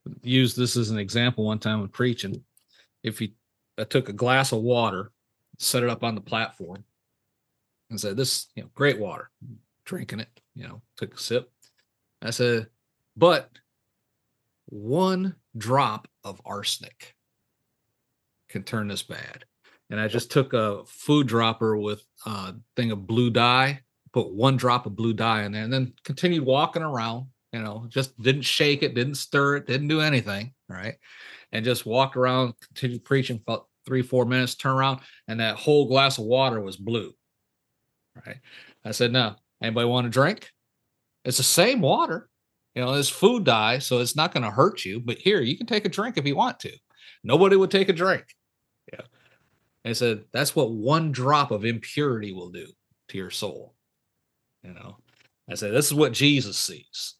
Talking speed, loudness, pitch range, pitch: 180 wpm, -24 LUFS, 110-135 Hz, 125 Hz